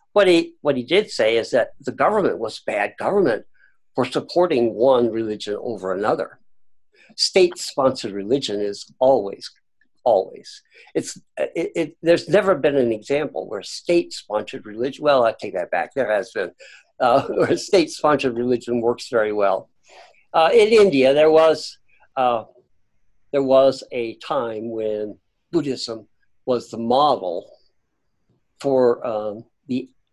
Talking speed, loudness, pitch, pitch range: 135 wpm, -20 LUFS, 130 Hz, 110-155 Hz